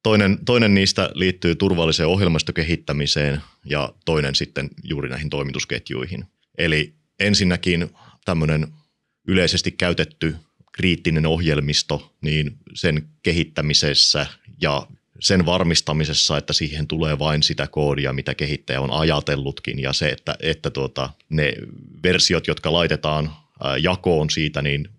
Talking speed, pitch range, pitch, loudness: 115 wpm, 75-85 Hz, 75 Hz, -20 LUFS